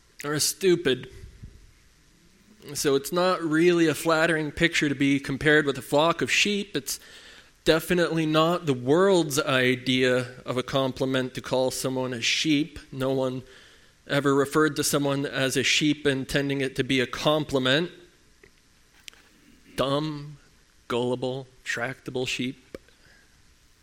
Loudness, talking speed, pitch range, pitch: -24 LUFS, 125 wpm, 130-155 Hz, 140 Hz